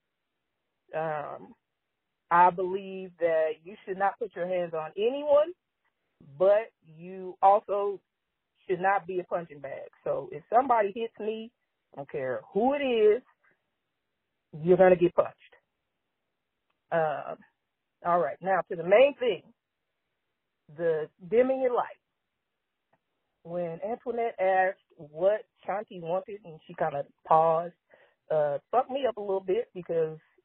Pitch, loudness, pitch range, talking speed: 190 Hz, -28 LUFS, 170-230 Hz, 135 wpm